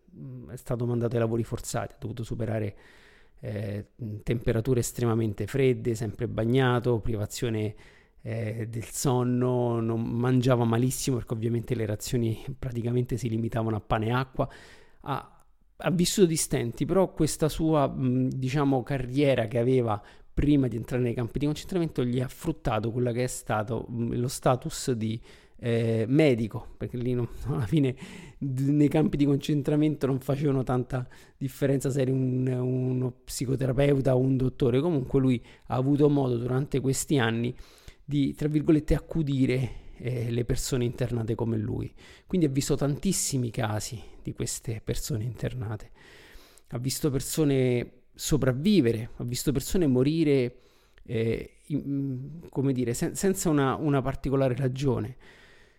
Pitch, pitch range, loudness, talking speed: 130 Hz, 115-140 Hz, -28 LUFS, 135 wpm